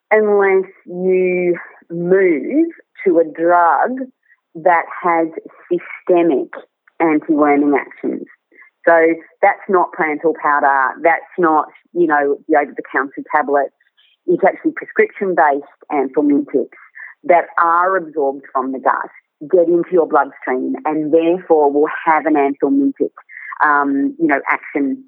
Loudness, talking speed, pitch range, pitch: -16 LUFS, 115 wpm, 150-200 Hz, 170 Hz